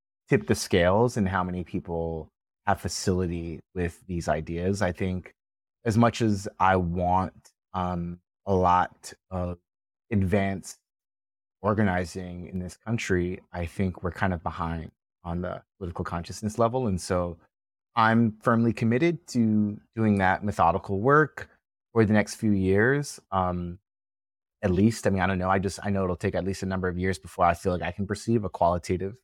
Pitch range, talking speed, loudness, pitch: 90-105 Hz, 170 wpm, -27 LUFS, 95 Hz